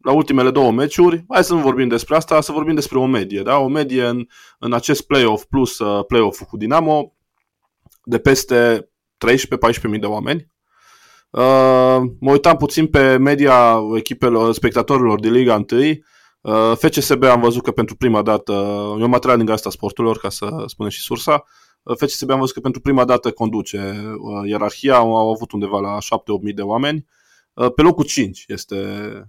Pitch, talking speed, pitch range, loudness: 120 Hz, 180 wpm, 110-140 Hz, -16 LUFS